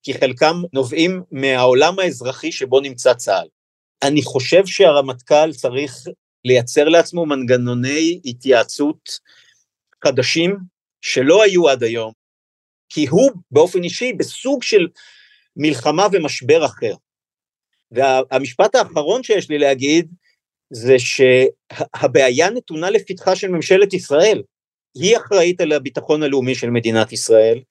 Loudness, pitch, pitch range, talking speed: -16 LUFS, 150 Hz, 130-185 Hz, 110 wpm